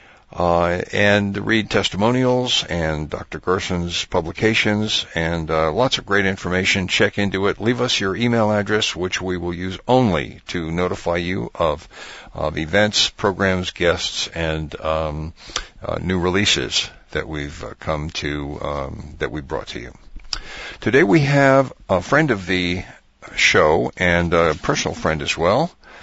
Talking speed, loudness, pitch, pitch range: 150 wpm, -19 LUFS, 90 Hz, 85-105 Hz